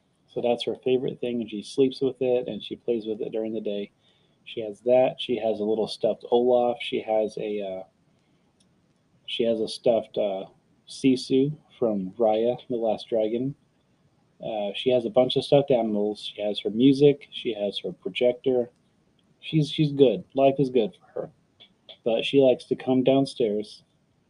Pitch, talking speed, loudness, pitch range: 125 Hz, 180 wpm, -25 LUFS, 110-135 Hz